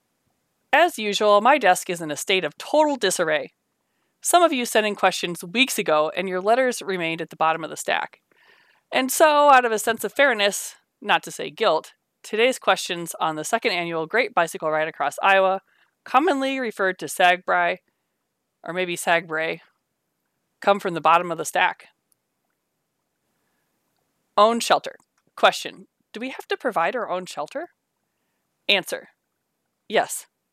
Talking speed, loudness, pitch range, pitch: 155 wpm, -21 LUFS, 170-235 Hz, 195 Hz